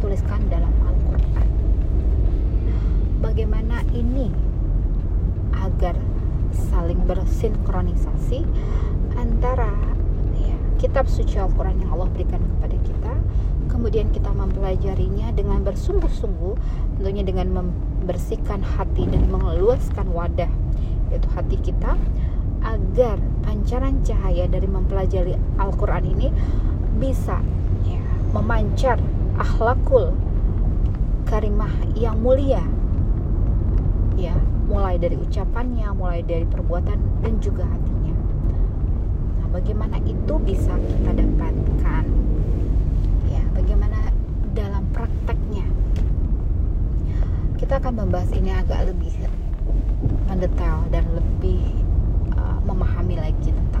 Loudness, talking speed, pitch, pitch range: -23 LUFS, 90 wpm, 90 Hz, 80-95 Hz